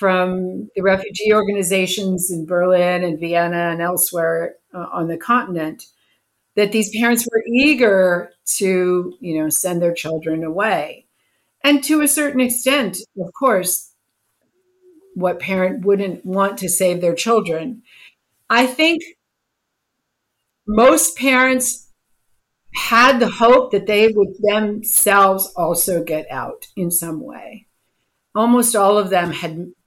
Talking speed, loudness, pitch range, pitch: 125 wpm, -17 LUFS, 175-235 Hz, 195 Hz